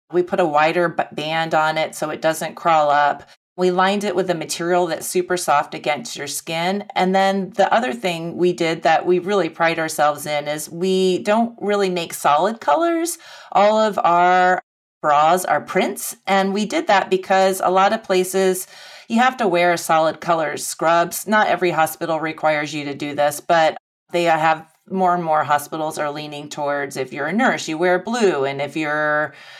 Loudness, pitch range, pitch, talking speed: -19 LUFS, 155-190 Hz, 175 Hz, 190 wpm